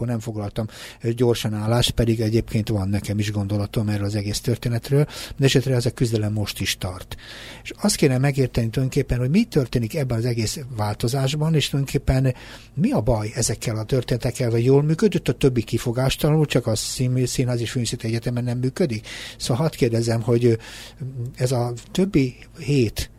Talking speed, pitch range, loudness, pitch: 165 wpm, 115-135 Hz, -22 LUFS, 120 Hz